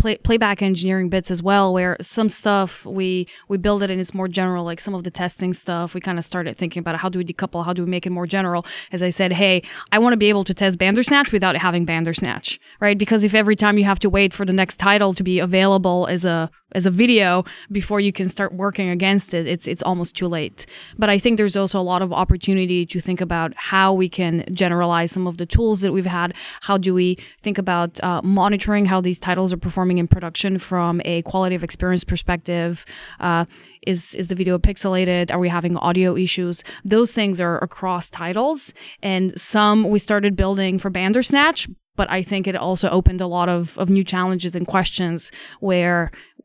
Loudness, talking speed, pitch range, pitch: -19 LUFS, 220 wpm, 175-195 Hz, 185 Hz